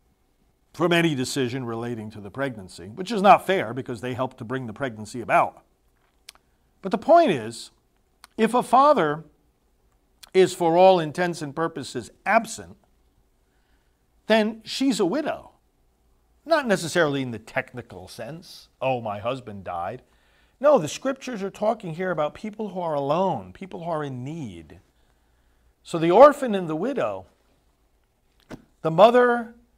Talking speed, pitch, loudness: 145 wpm, 155 Hz, -23 LUFS